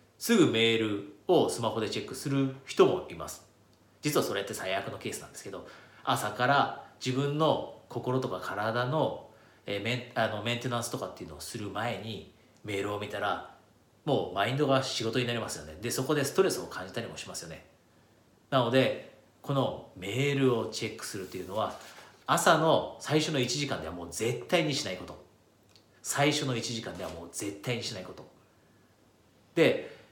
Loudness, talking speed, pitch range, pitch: -30 LUFS, 345 characters per minute, 100-130 Hz, 120 Hz